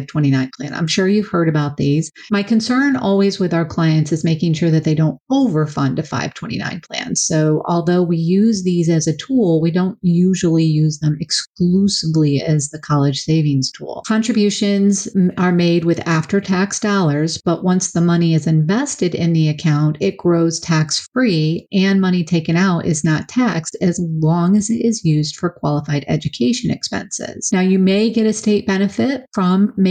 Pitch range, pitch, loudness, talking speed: 155-195 Hz, 170 Hz, -17 LUFS, 175 wpm